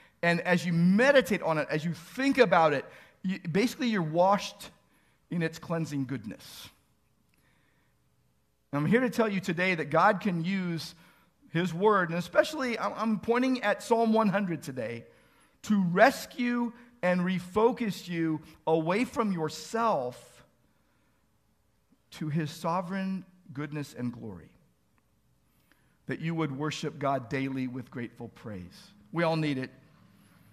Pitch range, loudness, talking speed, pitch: 155-210 Hz, -29 LUFS, 130 wpm, 175 Hz